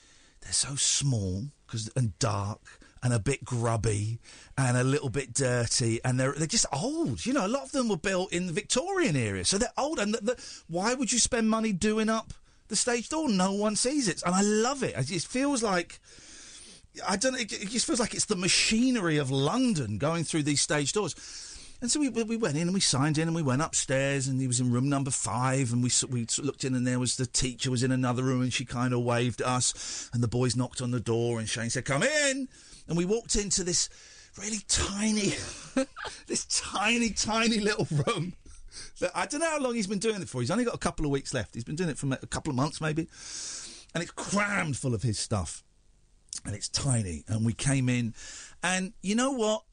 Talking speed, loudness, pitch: 230 wpm, -28 LUFS, 150 Hz